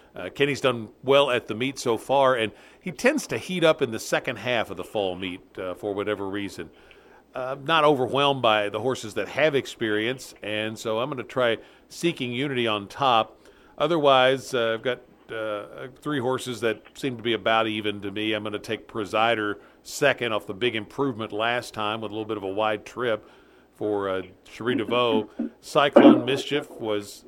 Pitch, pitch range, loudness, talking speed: 115 Hz, 105-135 Hz, -25 LUFS, 195 wpm